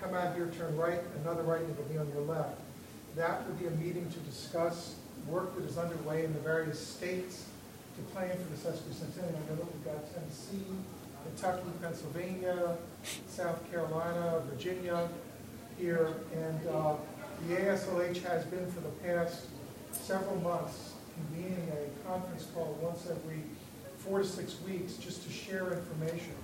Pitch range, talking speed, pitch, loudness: 160-180 Hz, 160 wpm, 170 Hz, -38 LUFS